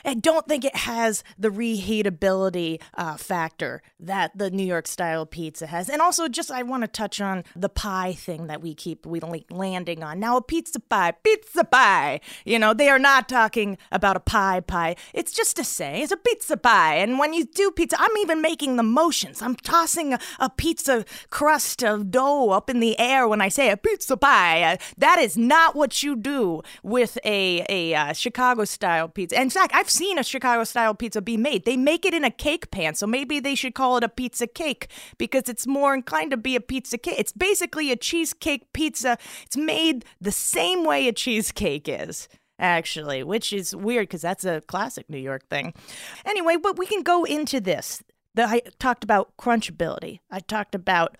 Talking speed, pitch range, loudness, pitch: 200 wpm, 195-295 Hz, -22 LUFS, 240 Hz